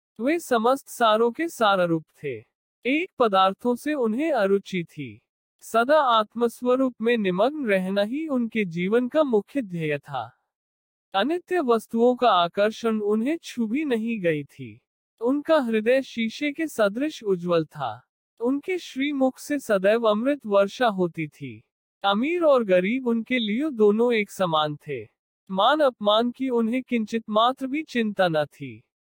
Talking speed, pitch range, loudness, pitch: 140 wpm, 195-260 Hz, -23 LUFS, 230 Hz